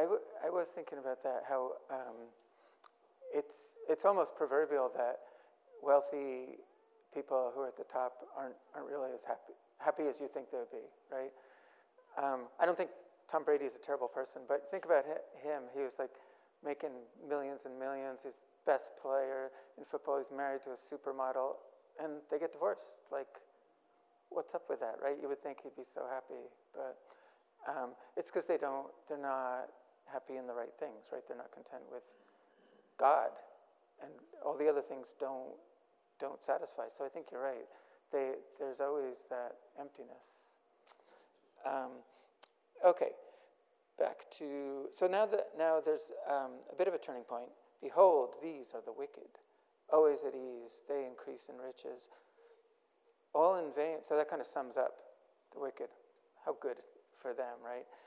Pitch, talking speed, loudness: 140 Hz, 170 wpm, -38 LUFS